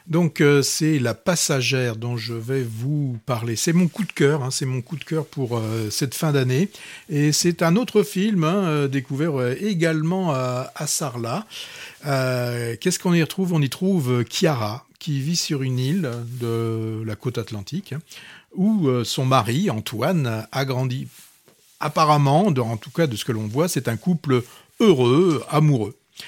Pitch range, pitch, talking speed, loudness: 125-165 Hz, 140 Hz, 175 wpm, -22 LUFS